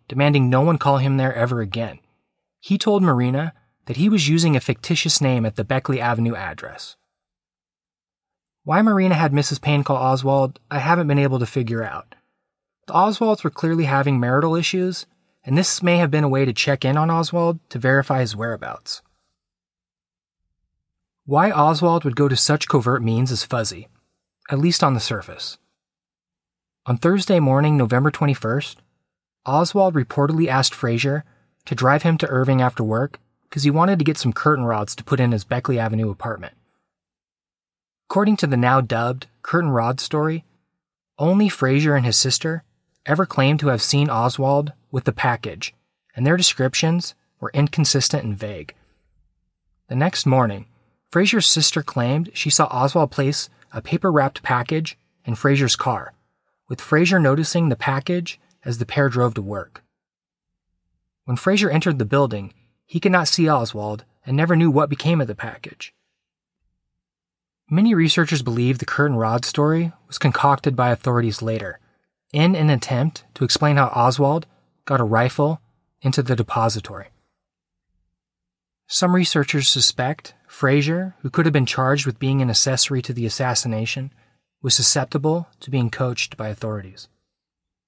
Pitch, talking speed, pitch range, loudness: 135 Hz, 155 wpm, 120-155 Hz, -19 LUFS